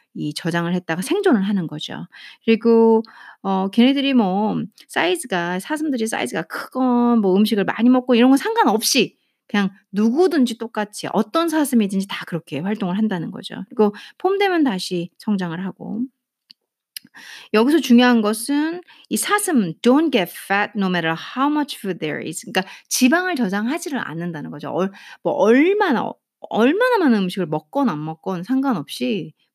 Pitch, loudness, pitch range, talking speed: 225 Hz, -19 LUFS, 190-265 Hz, 365 characters per minute